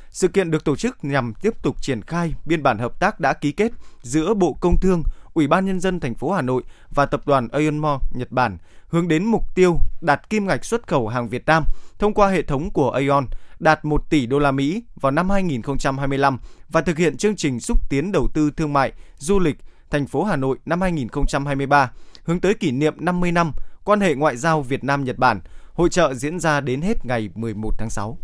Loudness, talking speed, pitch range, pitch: -21 LUFS, 225 wpm, 135-175 Hz, 150 Hz